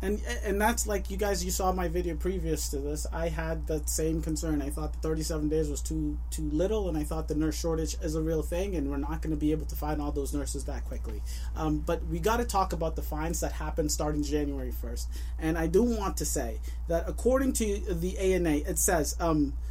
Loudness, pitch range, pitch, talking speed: -30 LUFS, 145-180 Hz, 160 Hz, 240 wpm